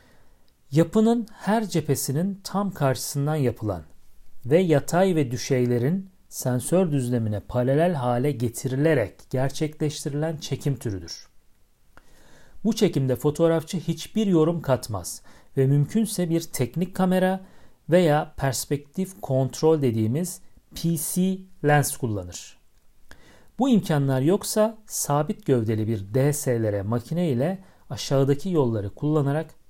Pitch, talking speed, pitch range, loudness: 145 Hz, 95 wpm, 125-175 Hz, -24 LUFS